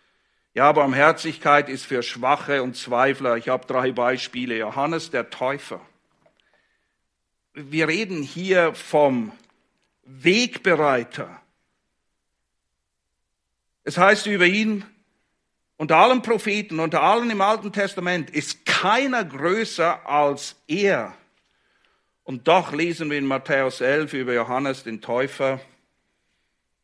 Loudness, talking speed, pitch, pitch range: -21 LUFS, 105 wpm, 145 Hz, 125-175 Hz